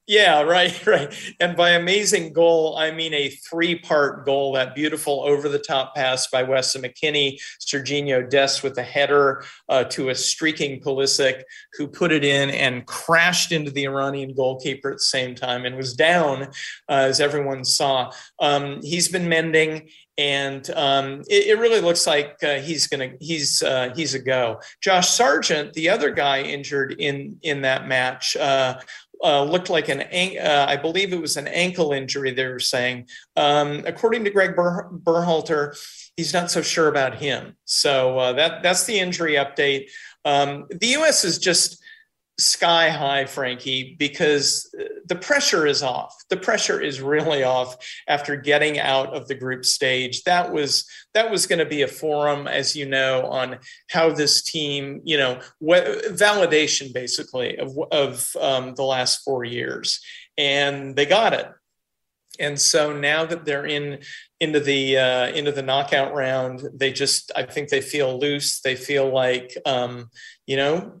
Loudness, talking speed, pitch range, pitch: -20 LUFS, 165 wpm, 135-165 Hz, 145 Hz